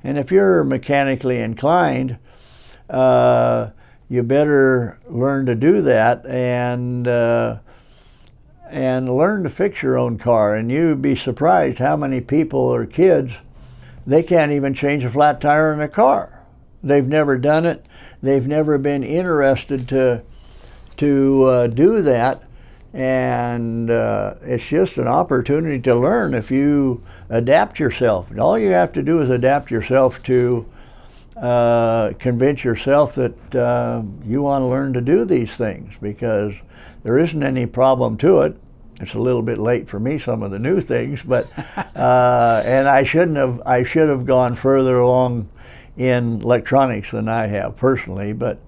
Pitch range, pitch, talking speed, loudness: 120-140 Hz, 130 Hz, 155 wpm, -17 LUFS